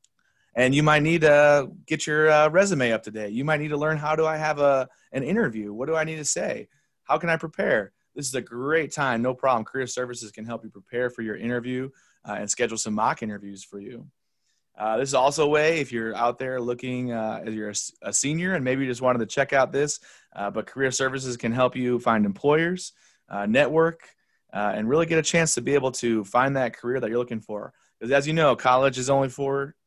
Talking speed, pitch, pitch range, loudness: 225 wpm, 130 Hz, 115-150 Hz, -24 LUFS